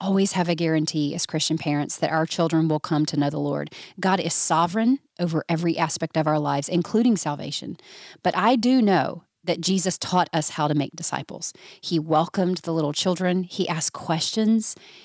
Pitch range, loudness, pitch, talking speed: 155-185 Hz, -23 LUFS, 165 Hz, 185 wpm